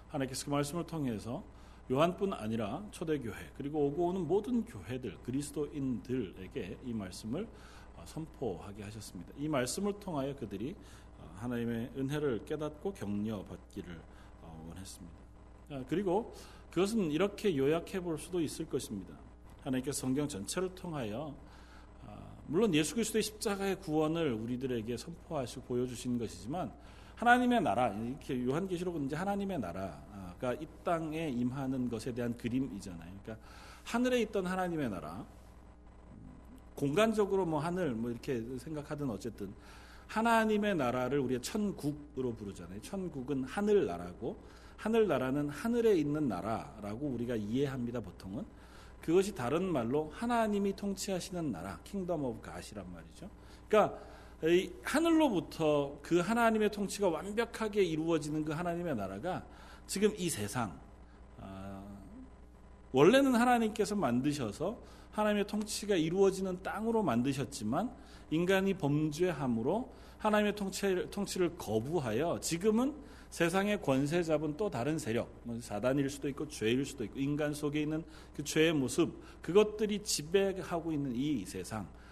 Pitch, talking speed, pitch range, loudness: 150 Hz, 330 characters per minute, 120-190 Hz, -34 LUFS